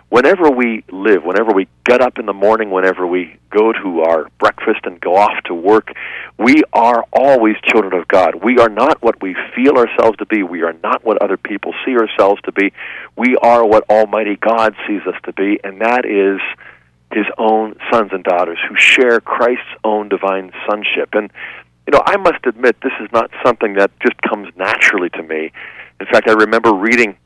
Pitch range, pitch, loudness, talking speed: 95-115 Hz, 110 Hz, -13 LUFS, 200 wpm